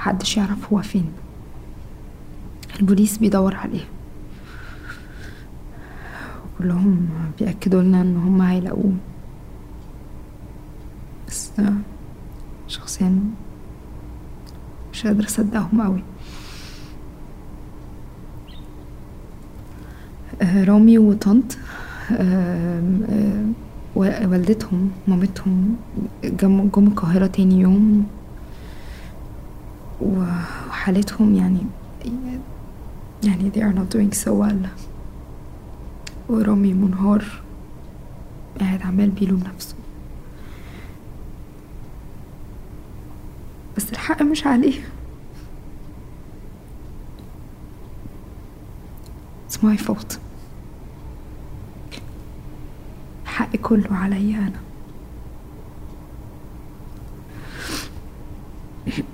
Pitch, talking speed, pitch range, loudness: 195 Hz, 55 wpm, 180-210 Hz, -19 LUFS